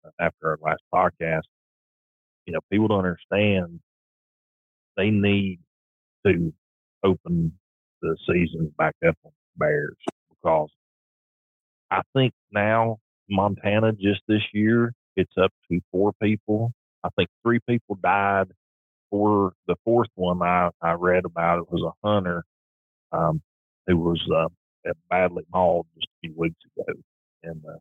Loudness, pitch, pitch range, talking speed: -24 LUFS, 90 Hz, 80-105 Hz, 135 wpm